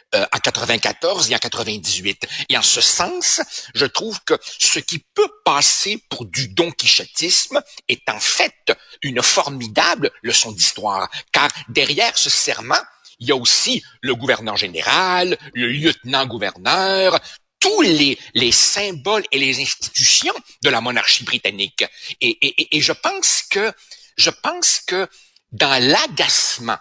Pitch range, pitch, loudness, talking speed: 125-205 Hz, 160 Hz, -16 LUFS, 140 wpm